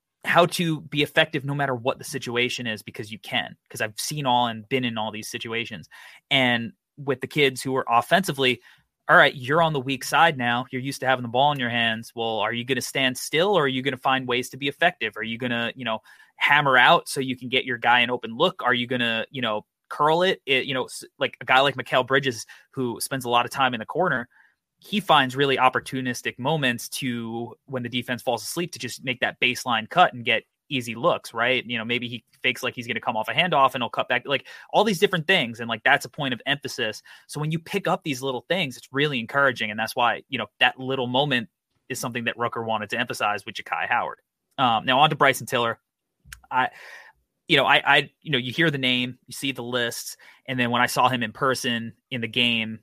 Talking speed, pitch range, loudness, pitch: 250 wpm, 120-140 Hz, -23 LUFS, 125 Hz